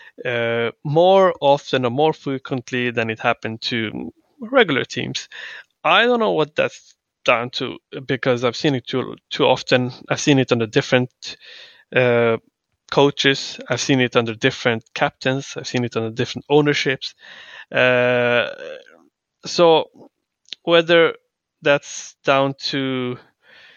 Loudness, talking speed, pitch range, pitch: -19 LUFS, 130 wpm, 125-155 Hz, 135 Hz